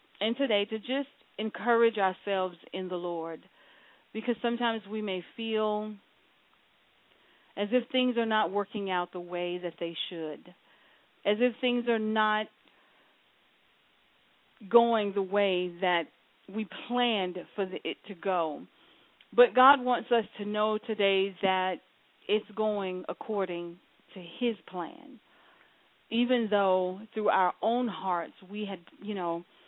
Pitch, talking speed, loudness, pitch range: 205 Hz, 135 wpm, -30 LUFS, 185-225 Hz